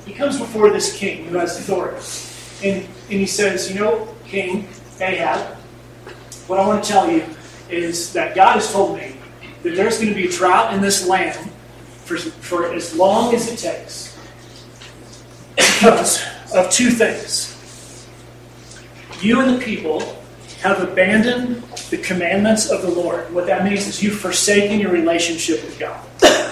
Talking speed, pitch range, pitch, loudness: 160 wpm, 170-210 Hz, 190 Hz, -17 LUFS